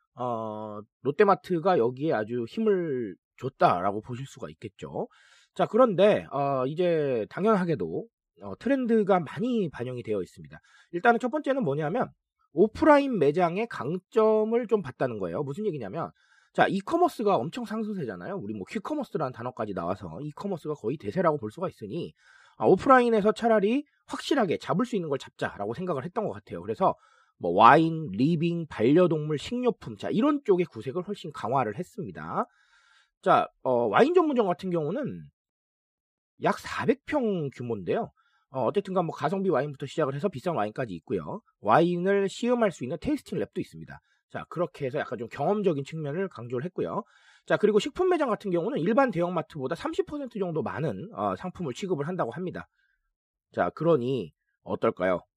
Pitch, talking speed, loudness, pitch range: 185 Hz, 355 characters per minute, -27 LUFS, 145-220 Hz